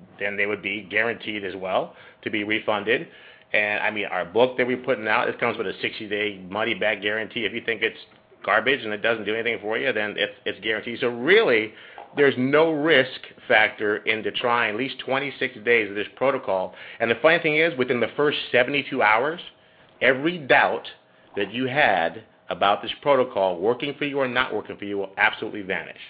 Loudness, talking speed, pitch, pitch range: -23 LUFS, 200 wpm, 120 Hz, 105-140 Hz